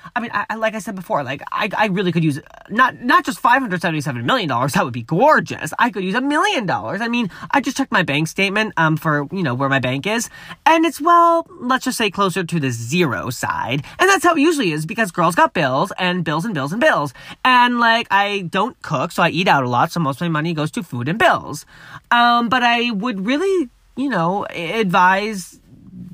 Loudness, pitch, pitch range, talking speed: -17 LUFS, 200 Hz, 160-245 Hz, 230 wpm